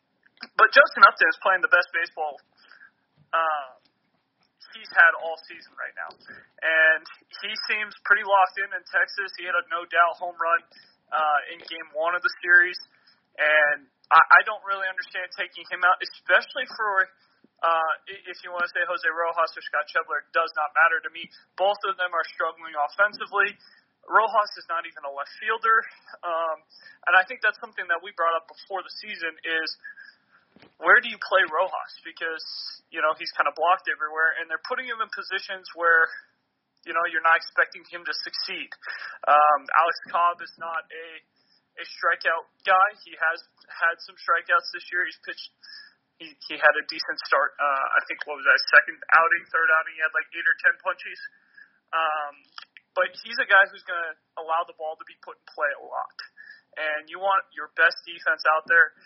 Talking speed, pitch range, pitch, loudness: 185 wpm, 160-200 Hz, 175 Hz, -23 LUFS